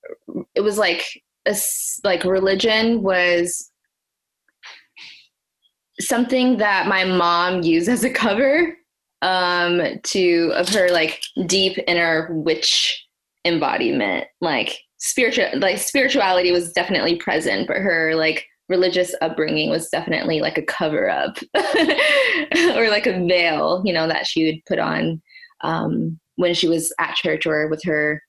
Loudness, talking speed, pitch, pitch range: -19 LUFS, 130 wpm, 180 Hz, 165-225 Hz